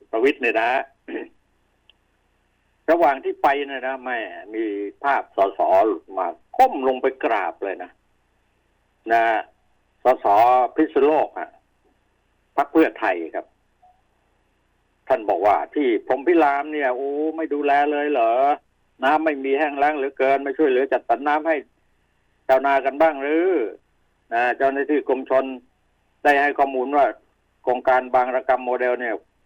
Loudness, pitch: -21 LUFS, 145 Hz